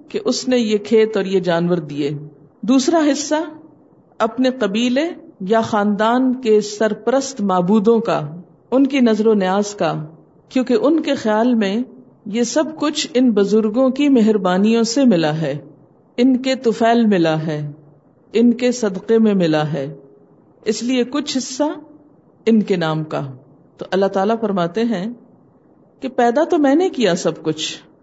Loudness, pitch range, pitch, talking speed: -17 LUFS, 175-255 Hz, 220 Hz, 155 wpm